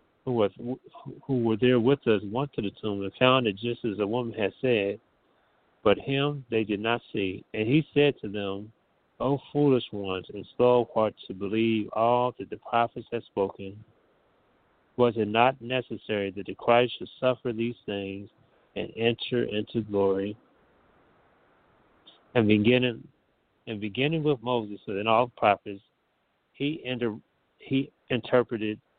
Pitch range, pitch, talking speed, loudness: 105-125 Hz, 115 Hz, 155 wpm, -27 LUFS